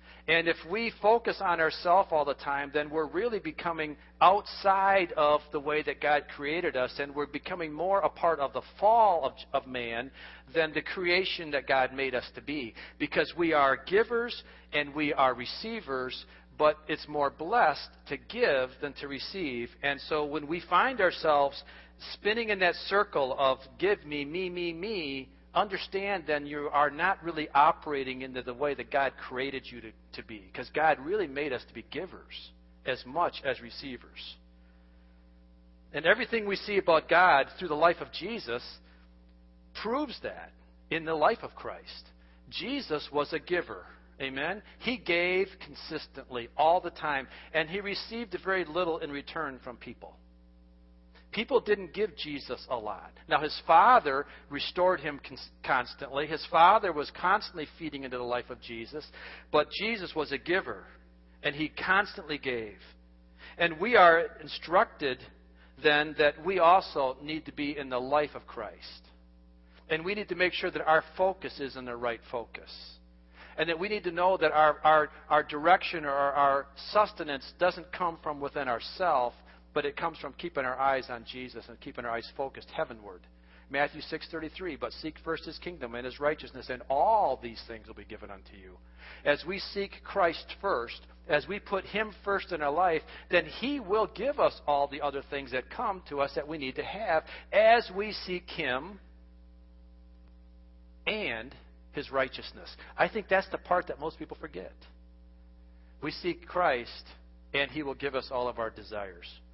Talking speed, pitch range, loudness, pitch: 175 wpm, 110-170 Hz, -29 LUFS, 145 Hz